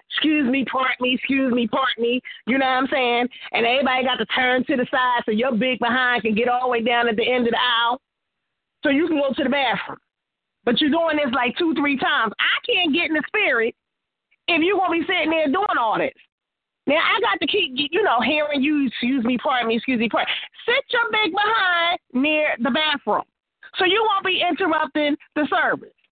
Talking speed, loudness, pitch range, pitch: 225 wpm, -20 LUFS, 250-335 Hz, 280 Hz